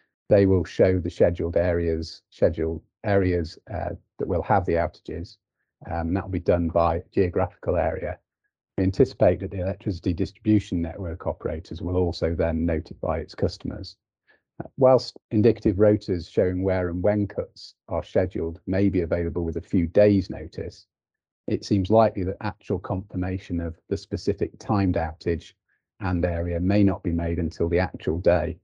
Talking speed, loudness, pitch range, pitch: 160 wpm, -25 LUFS, 85-100 Hz, 90 Hz